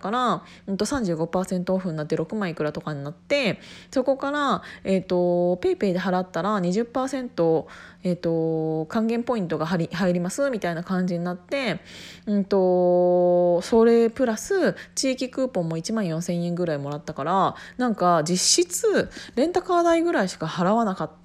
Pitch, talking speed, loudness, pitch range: 185 Hz, 300 characters per minute, -24 LUFS, 175-235 Hz